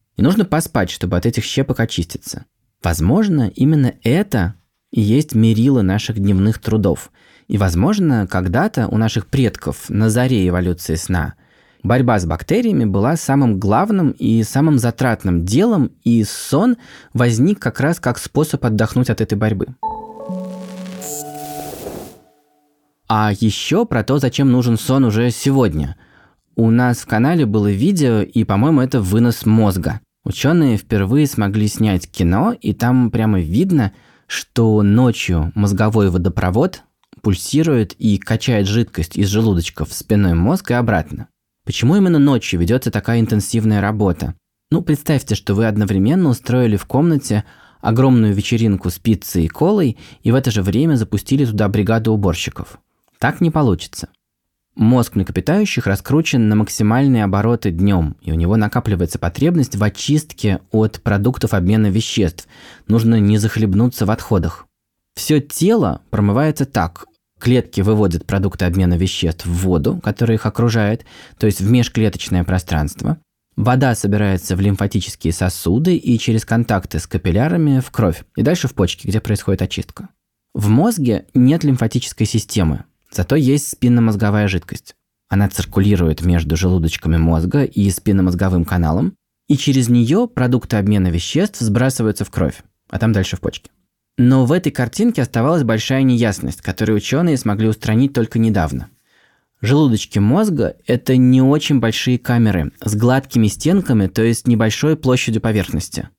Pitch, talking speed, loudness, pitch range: 110 Hz, 135 wpm, -16 LUFS, 100-125 Hz